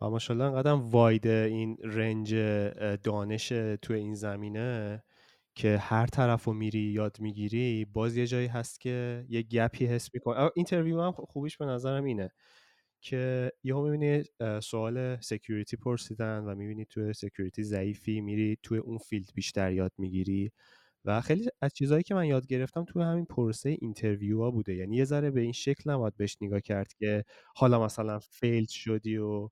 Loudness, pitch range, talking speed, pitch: -31 LUFS, 105-125 Hz, 165 wpm, 115 Hz